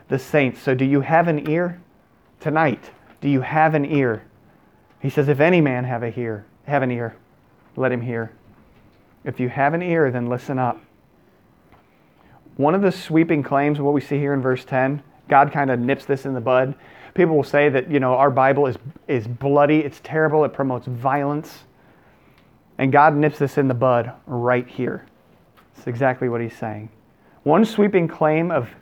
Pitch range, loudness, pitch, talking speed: 125-150 Hz, -20 LUFS, 140 Hz, 185 wpm